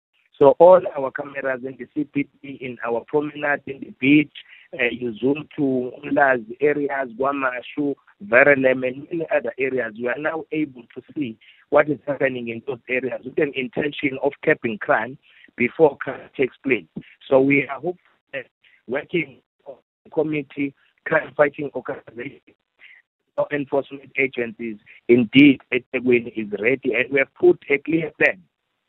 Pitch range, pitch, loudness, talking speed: 125-150 Hz, 140 Hz, -21 LUFS, 150 wpm